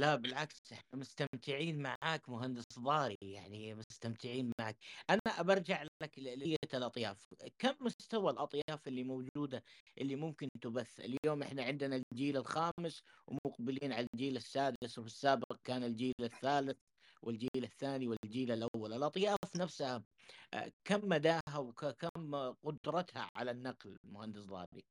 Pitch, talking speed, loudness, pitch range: 135 Hz, 125 wpm, -40 LUFS, 120-150 Hz